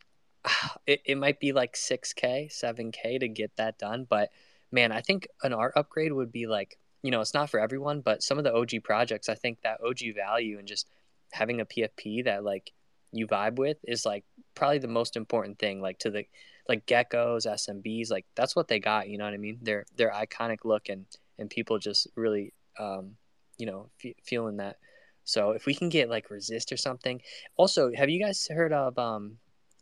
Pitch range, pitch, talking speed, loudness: 105-130 Hz, 115 Hz, 205 wpm, -30 LUFS